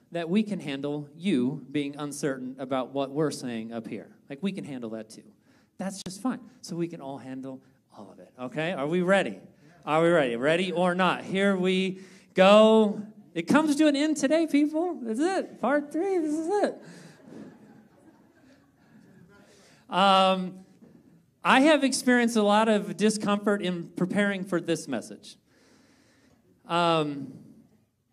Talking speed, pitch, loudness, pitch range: 150 wpm, 185 Hz, -26 LUFS, 150-215 Hz